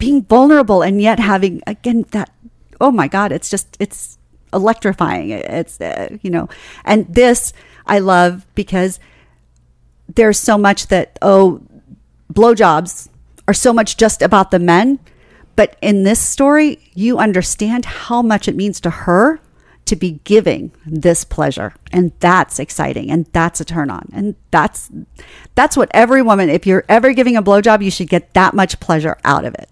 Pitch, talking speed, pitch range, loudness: 200 Hz, 165 wpm, 180-225 Hz, -13 LUFS